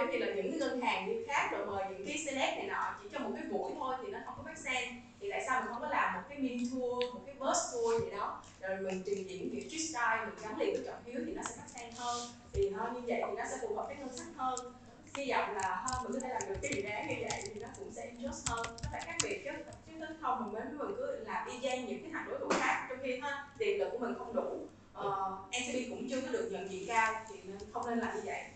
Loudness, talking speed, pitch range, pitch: -38 LUFS, 290 wpm, 225-300 Hz, 250 Hz